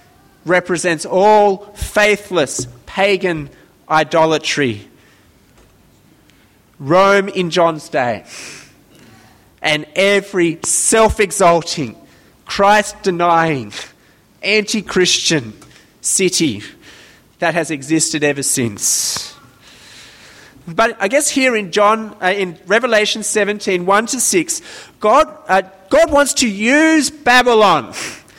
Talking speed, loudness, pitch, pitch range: 80 wpm, -14 LUFS, 190 Hz, 160-215 Hz